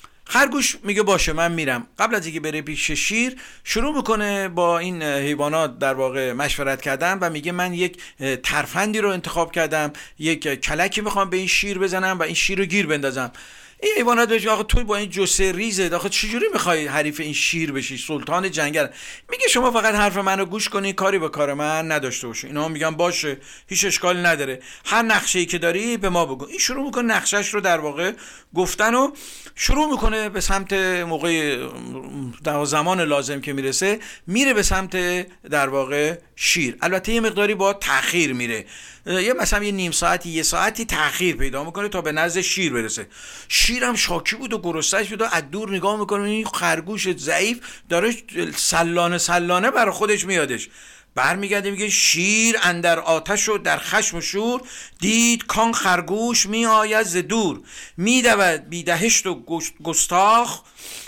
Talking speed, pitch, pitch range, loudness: 170 wpm, 185 Hz, 160-215 Hz, -20 LUFS